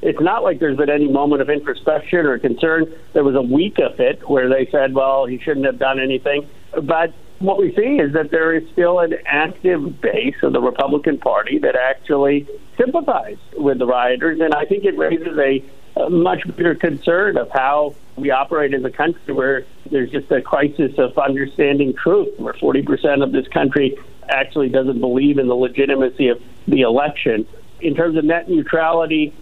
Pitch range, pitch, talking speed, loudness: 135-165 Hz, 145 Hz, 185 wpm, -17 LUFS